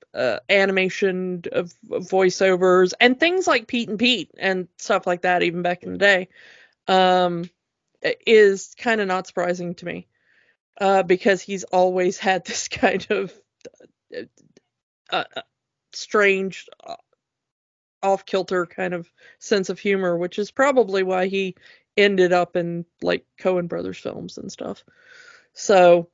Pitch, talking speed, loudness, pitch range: 190 Hz, 135 wpm, -20 LUFS, 180-215 Hz